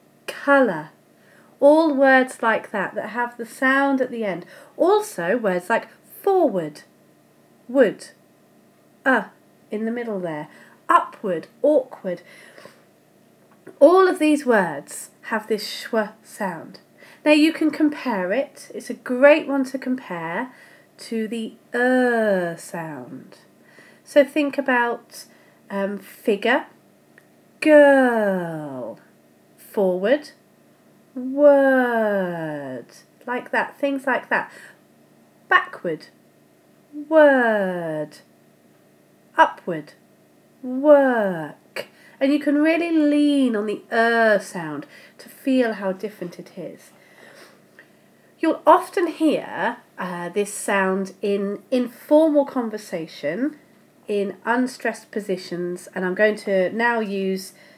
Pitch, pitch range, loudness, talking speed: 225 Hz, 185-280 Hz, -21 LUFS, 105 wpm